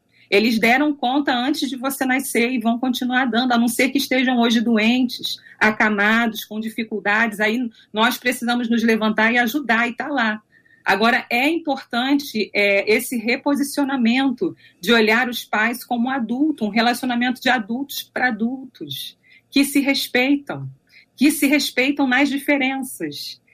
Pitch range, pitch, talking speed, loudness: 225-270 Hz, 245 Hz, 150 wpm, -19 LUFS